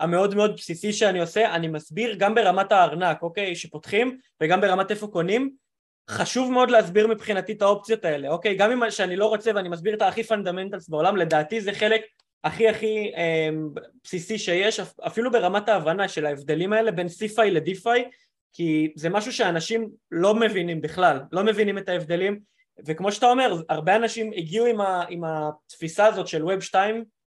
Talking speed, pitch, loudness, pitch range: 165 wpm, 200 Hz, -23 LUFS, 170-220 Hz